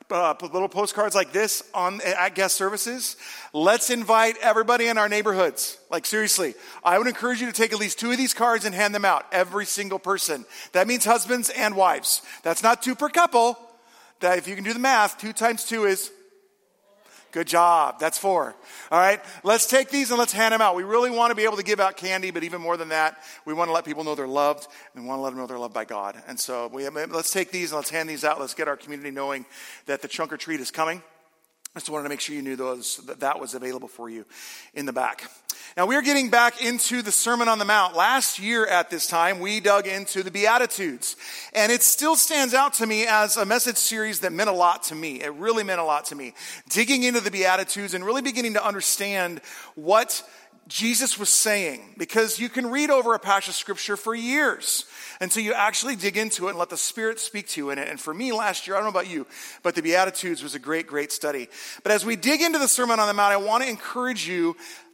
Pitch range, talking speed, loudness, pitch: 165-230 Hz, 245 wpm, -23 LUFS, 200 Hz